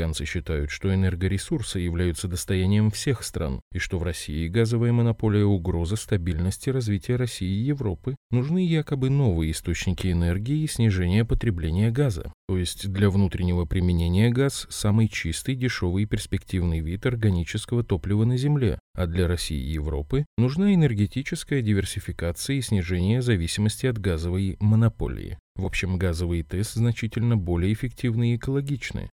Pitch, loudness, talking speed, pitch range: 100 Hz, -25 LUFS, 140 wpm, 90-120 Hz